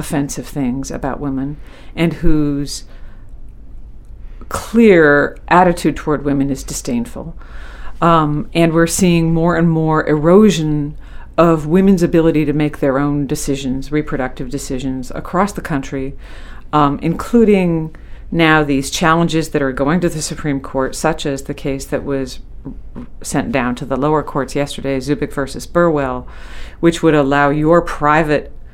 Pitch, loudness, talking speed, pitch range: 150 Hz, -15 LUFS, 140 wpm, 135-165 Hz